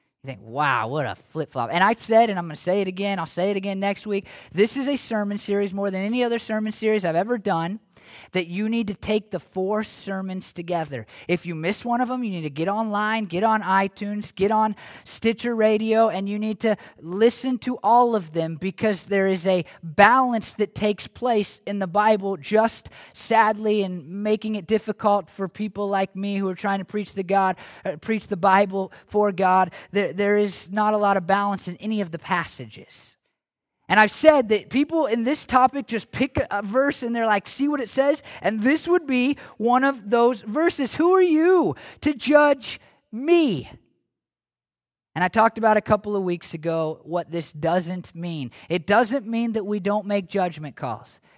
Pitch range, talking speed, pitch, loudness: 185-225 Hz, 200 wpm, 205 Hz, -23 LUFS